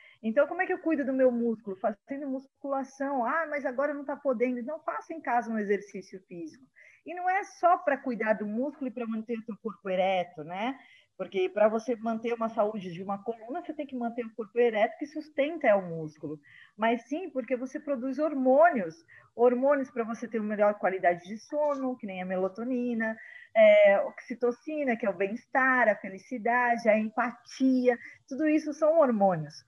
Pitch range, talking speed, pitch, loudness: 215-290 Hz, 190 wpm, 245 Hz, -29 LUFS